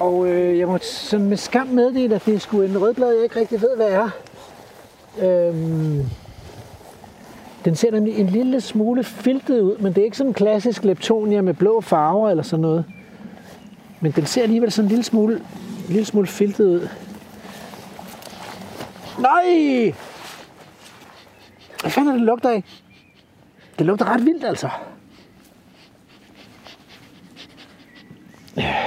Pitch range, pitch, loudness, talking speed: 190-230 Hz, 210 Hz, -19 LUFS, 145 wpm